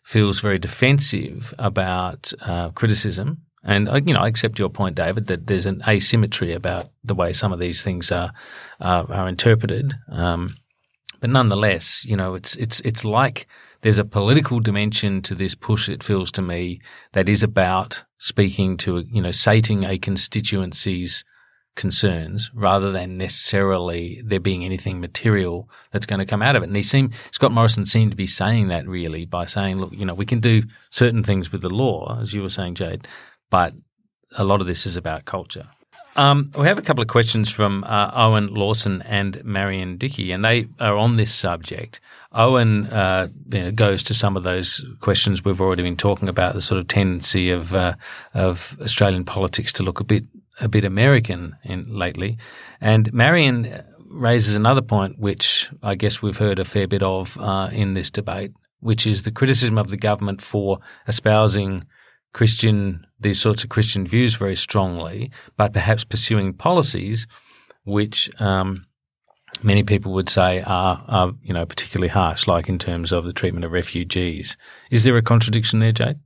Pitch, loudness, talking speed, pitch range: 100 Hz, -20 LUFS, 180 wpm, 95-115 Hz